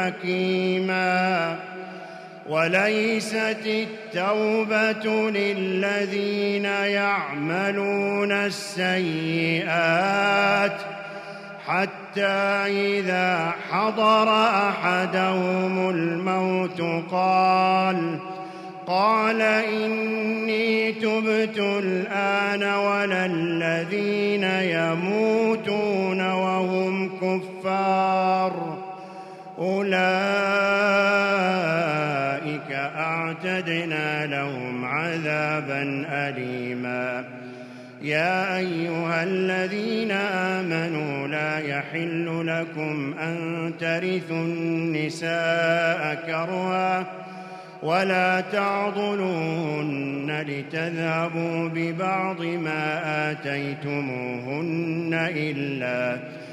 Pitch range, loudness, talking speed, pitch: 165-200 Hz, -24 LUFS, 45 wpm, 185 Hz